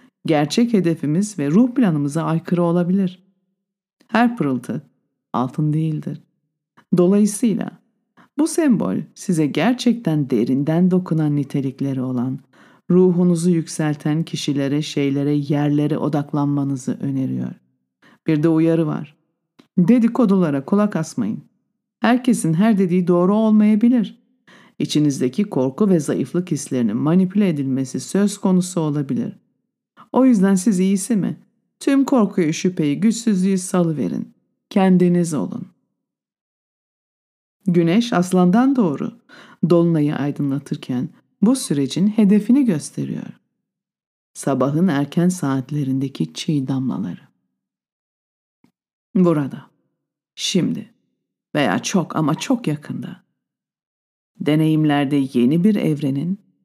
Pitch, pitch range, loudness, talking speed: 175 Hz, 145-210 Hz, -19 LUFS, 90 wpm